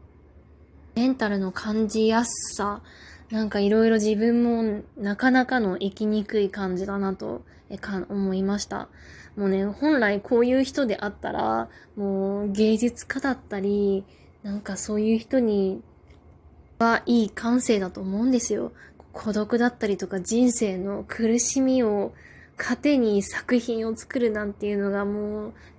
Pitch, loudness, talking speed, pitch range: 210 Hz, -24 LUFS, 270 characters per minute, 195-230 Hz